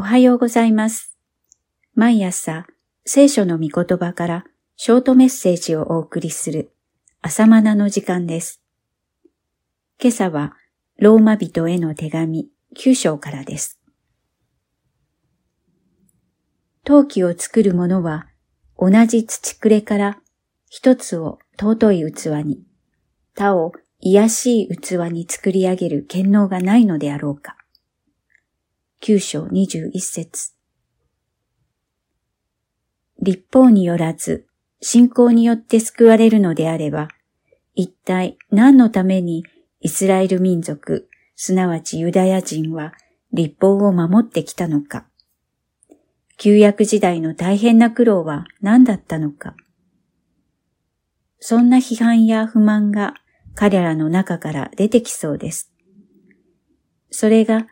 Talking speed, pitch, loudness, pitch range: 210 characters per minute, 195 Hz, -16 LUFS, 170-225 Hz